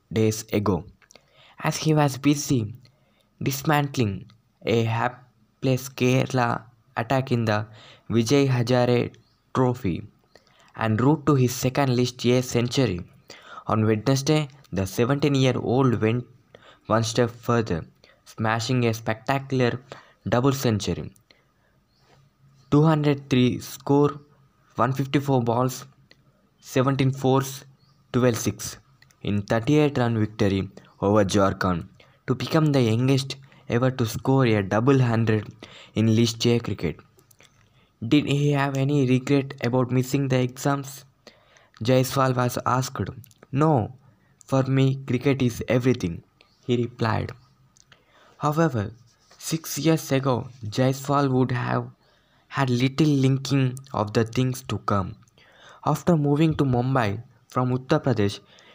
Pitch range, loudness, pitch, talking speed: 115-135 Hz, -24 LUFS, 125 Hz, 110 wpm